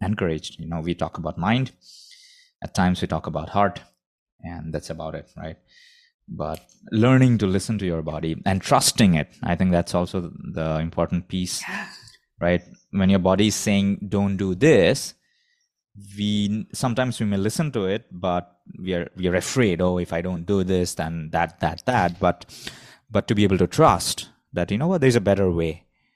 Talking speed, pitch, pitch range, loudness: 185 wpm, 95 Hz, 85-105 Hz, -23 LUFS